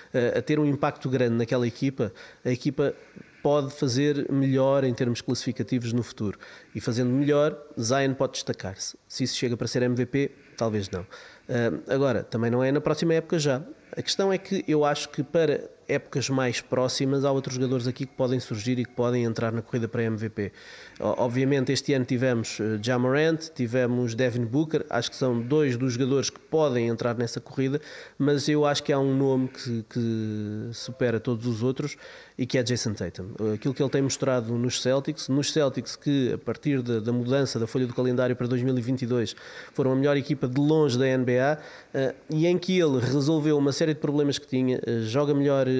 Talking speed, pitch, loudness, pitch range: 190 wpm, 130 Hz, -26 LUFS, 120-145 Hz